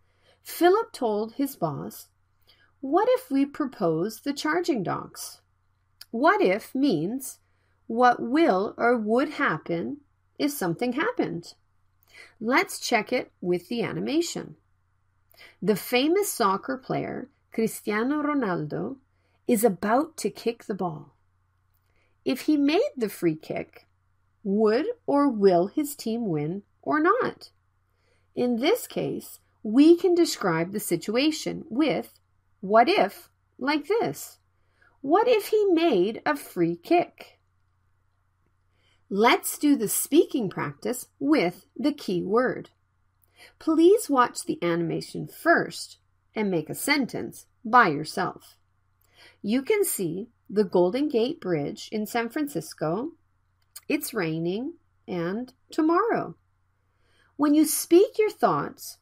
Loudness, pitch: -25 LUFS, 230 Hz